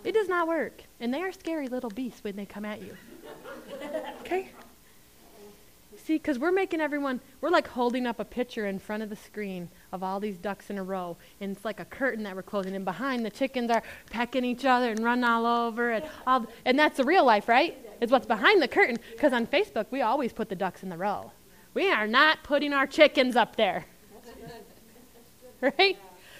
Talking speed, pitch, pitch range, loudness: 210 wpm, 240 Hz, 210-280 Hz, -27 LUFS